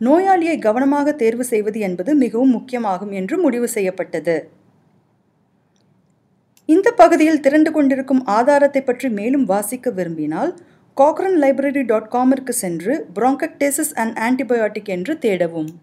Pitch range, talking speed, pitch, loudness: 210-285 Hz, 110 wpm, 255 Hz, -17 LUFS